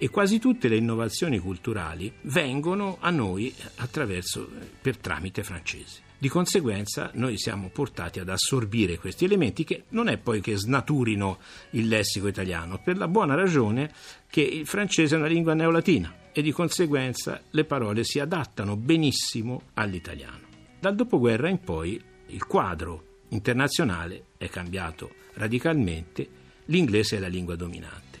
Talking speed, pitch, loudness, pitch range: 140 wpm, 115 Hz, -26 LUFS, 95-160 Hz